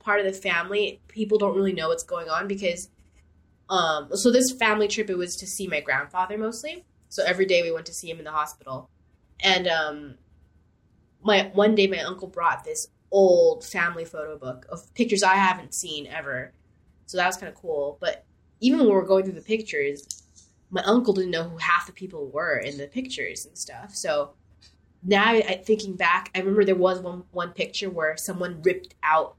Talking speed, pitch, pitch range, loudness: 200 wpm, 185 Hz, 160-205 Hz, -24 LUFS